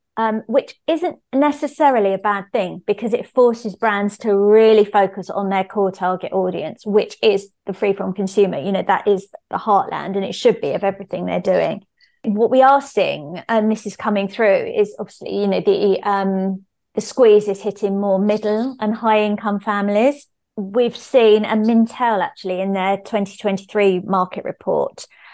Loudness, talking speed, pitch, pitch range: -18 LUFS, 175 wpm, 210 Hz, 195-230 Hz